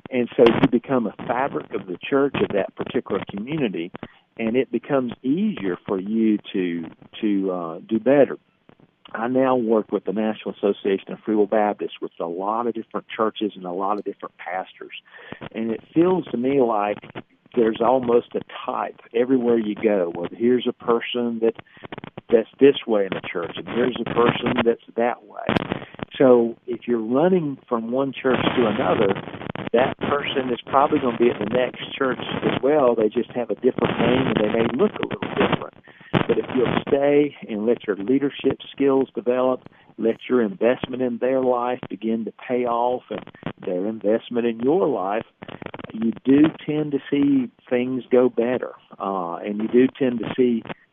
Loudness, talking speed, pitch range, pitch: -22 LUFS, 180 wpm, 110-130 Hz, 120 Hz